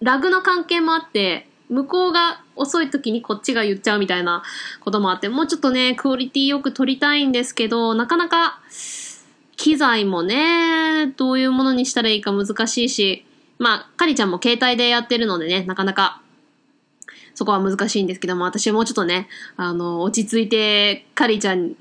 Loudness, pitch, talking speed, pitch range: -19 LUFS, 240 Hz, 380 characters per minute, 205-285 Hz